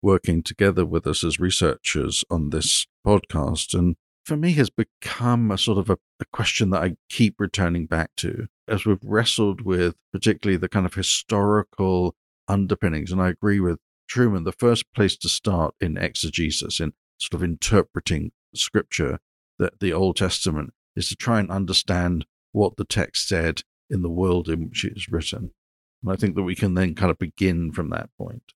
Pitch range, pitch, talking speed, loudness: 85-100 Hz, 95 Hz, 185 wpm, -23 LUFS